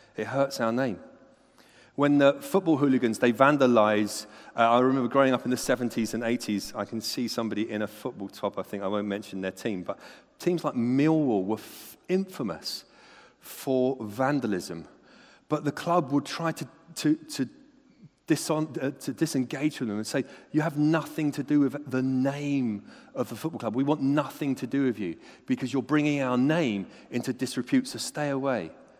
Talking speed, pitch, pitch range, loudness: 180 wpm, 135 Hz, 120-150 Hz, -27 LUFS